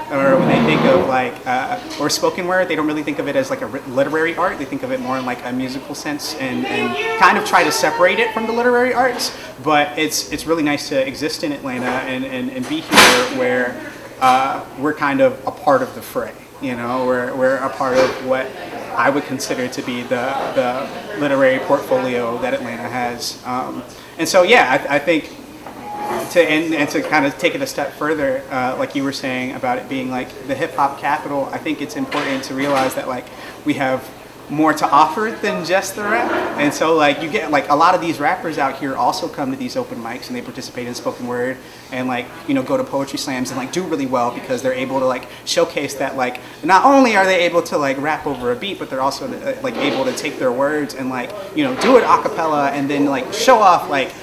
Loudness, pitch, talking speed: -18 LUFS, 150 Hz, 240 wpm